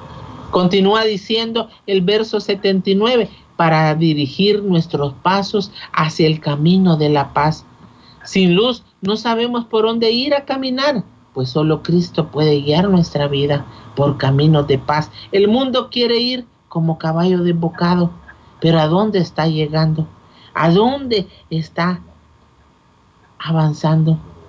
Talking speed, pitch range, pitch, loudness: 125 wpm, 150-205 Hz, 165 Hz, -16 LUFS